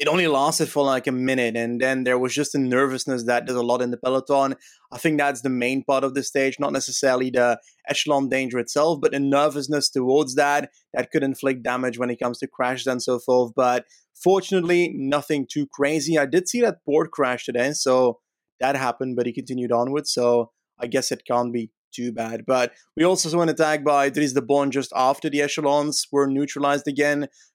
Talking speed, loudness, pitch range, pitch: 210 wpm, -22 LUFS, 125-145 Hz, 135 Hz